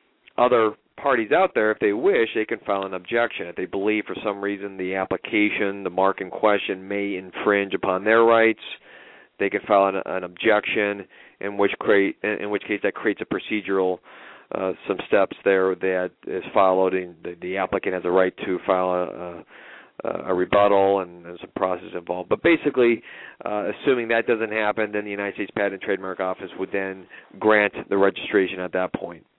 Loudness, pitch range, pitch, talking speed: -23 LUFS, 95-105 Hz, 100 Hz, 190 wpm